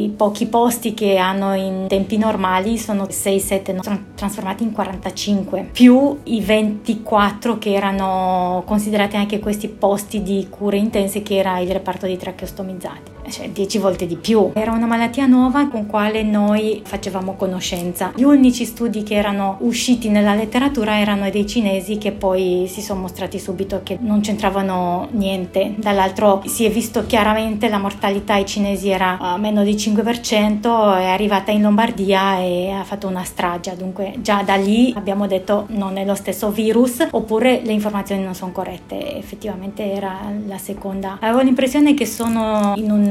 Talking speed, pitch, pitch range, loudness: 165 wpm, 205 Hz, 195-220 Hz, -18 LUFS